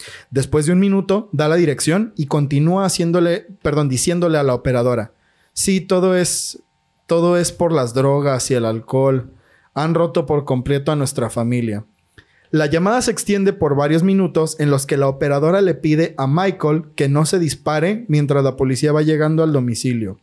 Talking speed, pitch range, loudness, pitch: 180 wpm, 135-175 Hz, -17 LUFS, 150 Hz